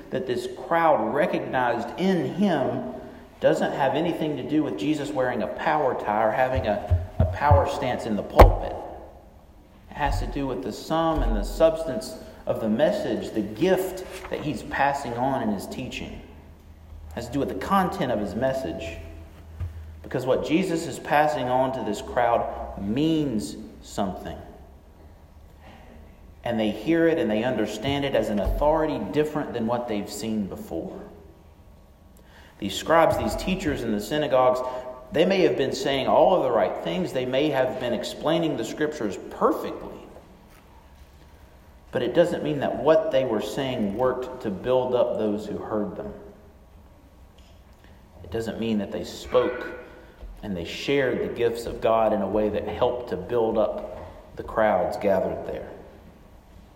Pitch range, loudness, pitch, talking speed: 85-140 Hz, -25 LUFS, 110 Hz, 160 wpm